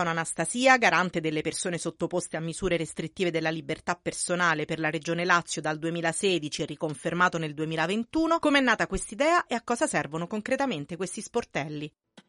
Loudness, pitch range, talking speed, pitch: -27 LUFS, 160-205 Hz, 145 wpm, 170 Hz